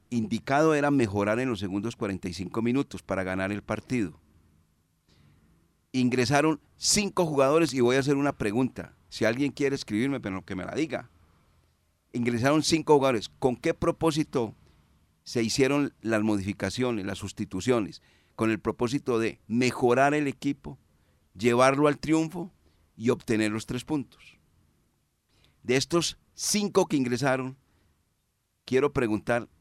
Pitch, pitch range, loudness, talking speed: 120 Hz, 95-140 Hz, -27 LUFS, 130 wpm